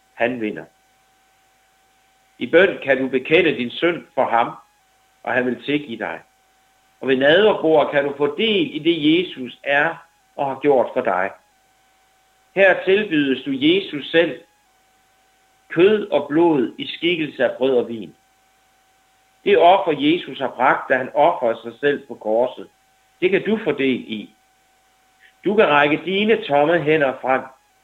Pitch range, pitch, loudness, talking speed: 130-220 Hz, 155 Hz, -19 LUFS, 155 wpm